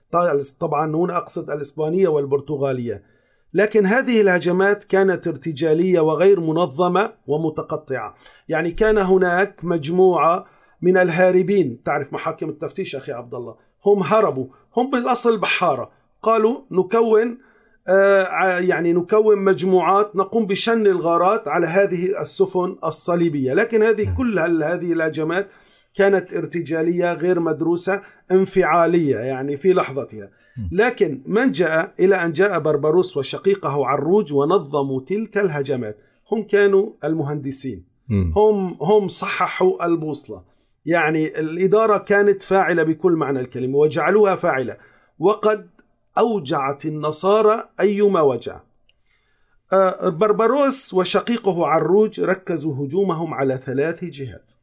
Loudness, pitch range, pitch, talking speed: -19 LUFS, 155-200 Hz, 180 Hz, 105 wpm